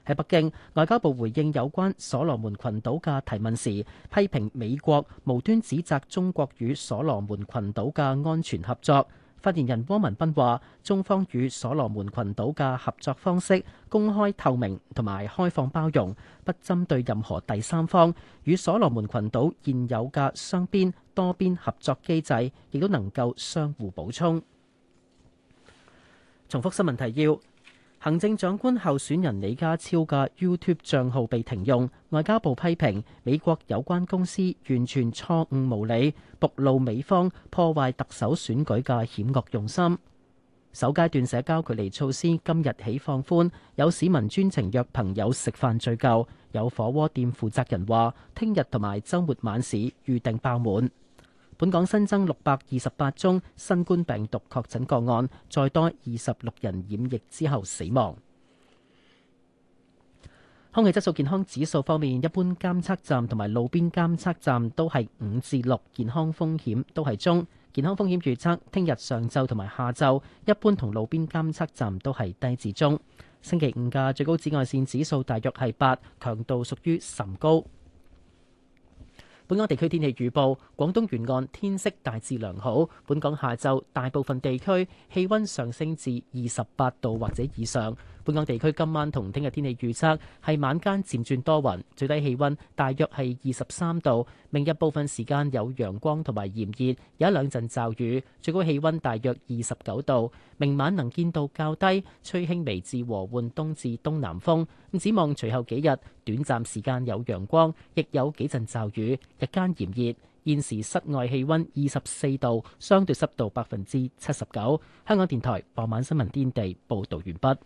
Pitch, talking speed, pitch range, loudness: 135 Hz, 255 characters per minute, 120-160 Hz, -27 LUFS